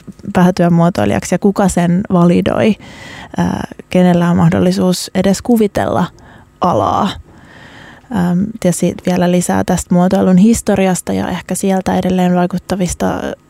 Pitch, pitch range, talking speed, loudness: 180 Hz, 175-190 Hz, 105 wpm, -13 LUFS